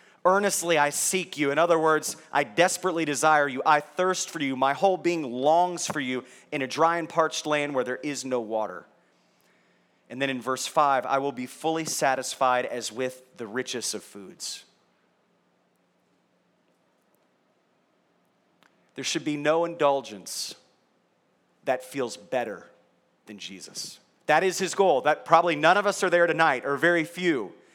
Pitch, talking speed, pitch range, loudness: 150 Hz, 160 wpm, 130-170 Hz, -25 LUFS